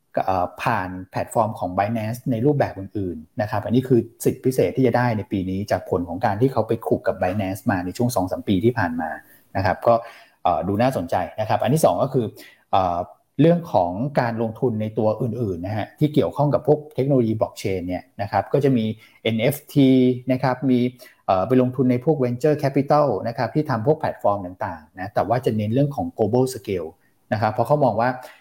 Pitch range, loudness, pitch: 105-130 Hz, -22 LUFS, 120 Hz